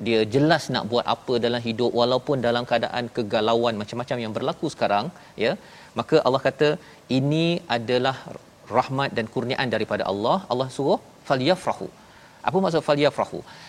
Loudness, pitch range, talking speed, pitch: -24 LUFS, 120-145 Hz, 140 wpm, 125 Hz